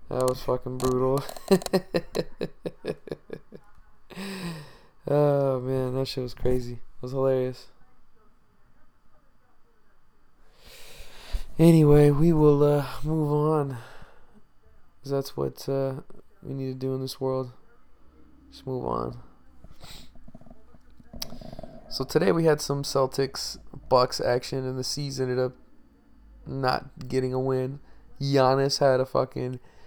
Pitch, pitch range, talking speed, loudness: 130 Hz, 125-145 Hz, 105 wpm, -26 LUFS